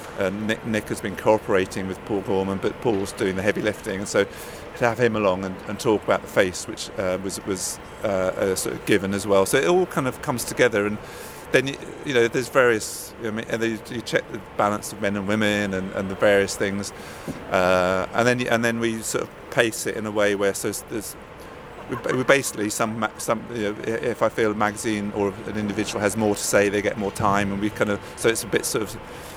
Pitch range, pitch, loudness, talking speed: 100-110 Hz, 105 Hz, -23 LUFS, 235 wpm